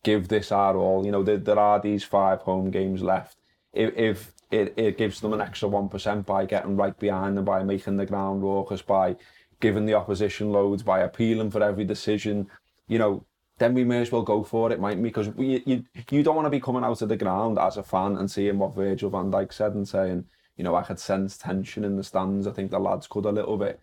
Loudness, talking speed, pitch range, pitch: -25 LUFS, 245 wpm, 95-110 Hz, 100 Hz